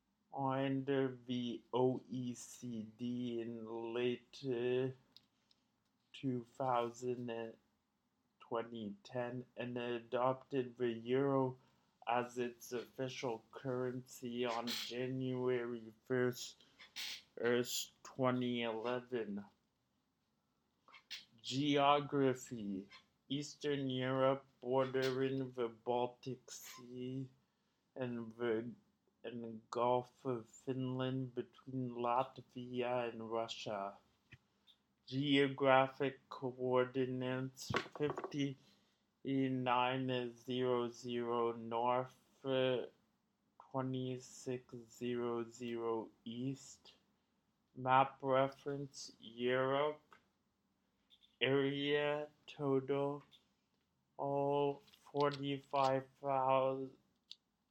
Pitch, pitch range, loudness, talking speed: 125 Hz, 120-135 Hz, -40 LUFS, 60 wpm